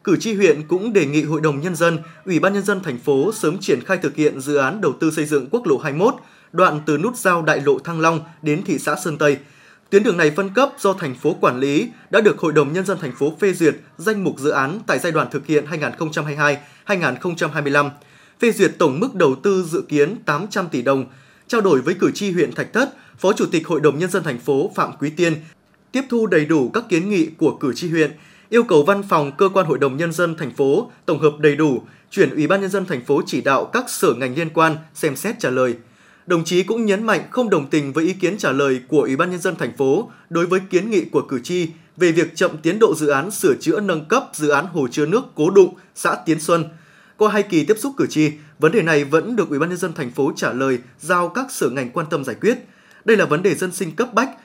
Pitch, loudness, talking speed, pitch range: 165 Hz, -19 LUFS, 255 wpm, 150-195 Hz